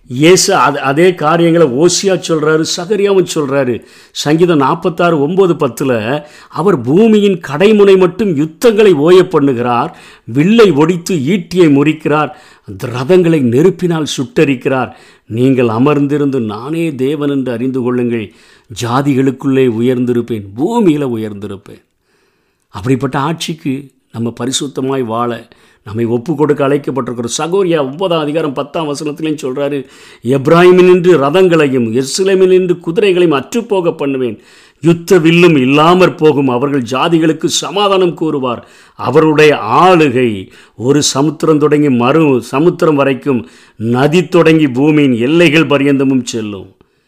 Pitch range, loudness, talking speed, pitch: 130-170 Hz, -11 LUFS, 100 wpm, 150 Hz